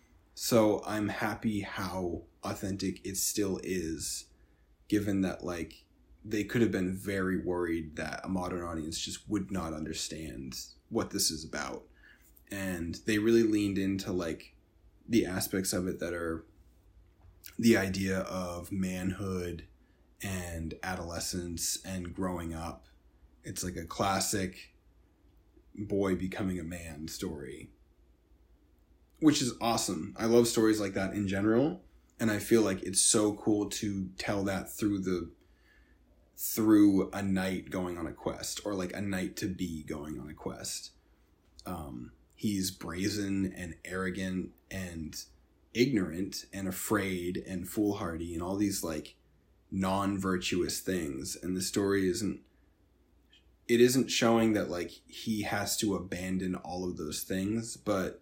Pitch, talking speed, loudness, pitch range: 95 Hz, 135 wpm, -32 LUFS, 85-100 Hz